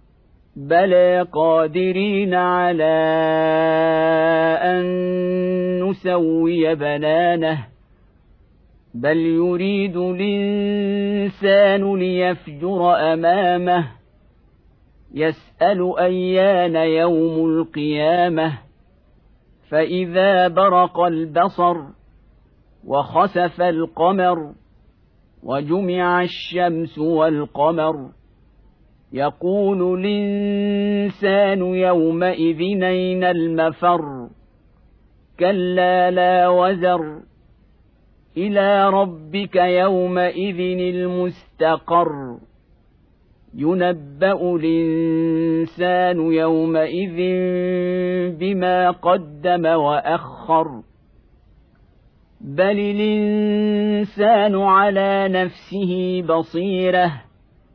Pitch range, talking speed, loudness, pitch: 160-185 Hz, 50 wpm, -18 LUFS, 180 Hz